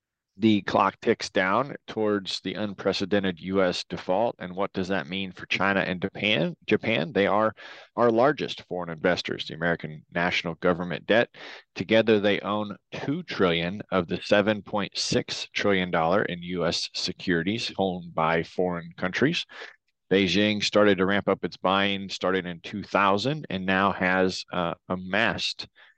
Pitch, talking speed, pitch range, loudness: 95 Hz, 140 wpm, 90-100 Hz, -26 LUFS